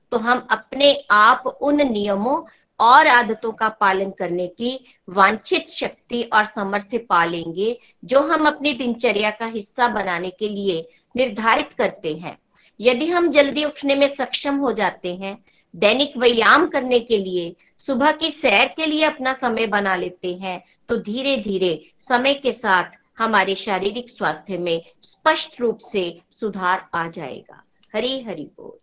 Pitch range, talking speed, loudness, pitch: 195-265 Hz, 150 wpm, -19 LUFS, 225 Hz